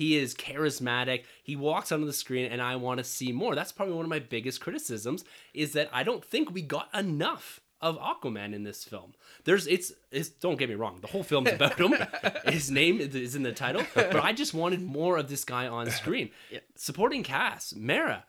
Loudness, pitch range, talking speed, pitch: -30 LUFS, 125-160 Hz, 215 wpm, 145 Hz